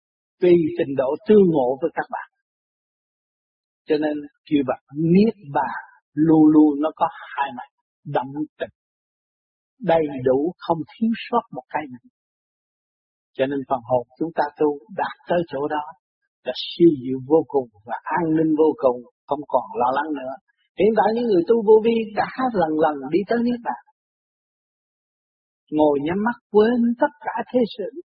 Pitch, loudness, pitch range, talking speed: 160 Hz, -21 LUFS, 145-220 Hz, 170 wpm